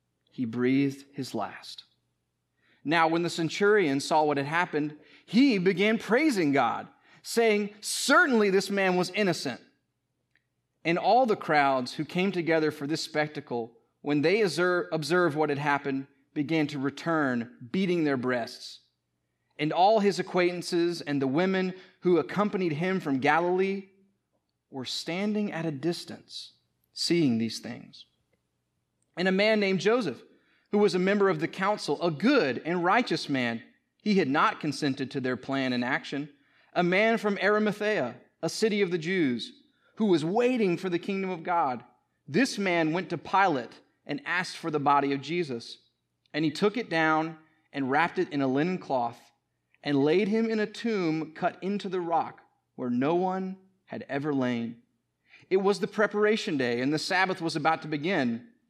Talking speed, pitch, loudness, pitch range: 165 wpm, 165 Hz, -27 LUFS, 140-195 Hz